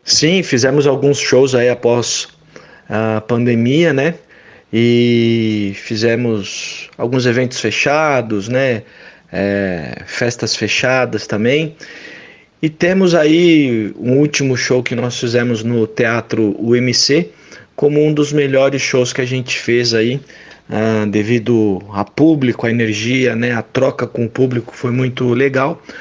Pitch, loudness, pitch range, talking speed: 125 Hz, -15 LUFS, 115-135 Hz, 130 wpm